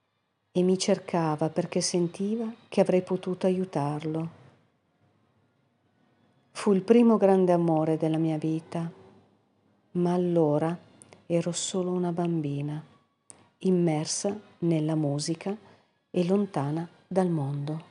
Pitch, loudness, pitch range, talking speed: 170 Hz, -27 LUFS, 150-185 Hz, 100 wpm